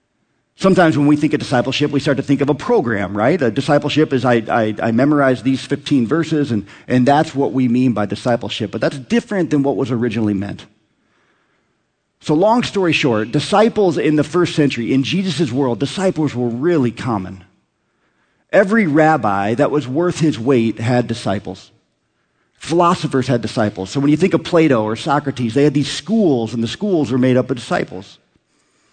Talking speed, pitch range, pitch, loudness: 185 wpm, 120-155 Hz, 140 Hz, -16 LUFS